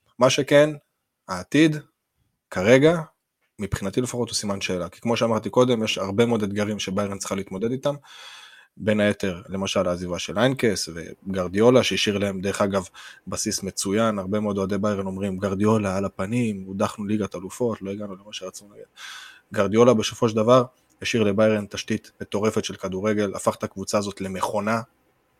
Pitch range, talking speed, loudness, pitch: 95-115 Hz, 155 wpm, -23 LUFS, 105 Hz